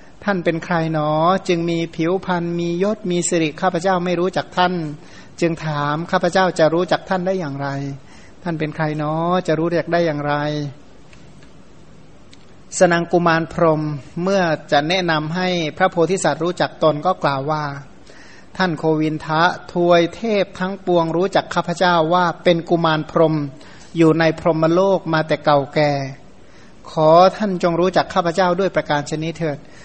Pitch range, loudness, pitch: 155-180 Hz, -18 LUFS, 165 Hz